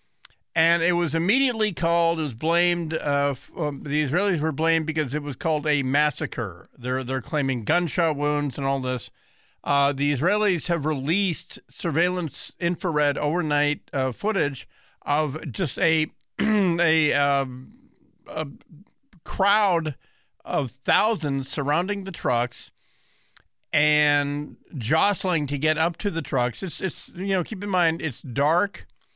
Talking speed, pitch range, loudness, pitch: 140 wpm, 145-175 Hz, -24 LUFS, 155 Hz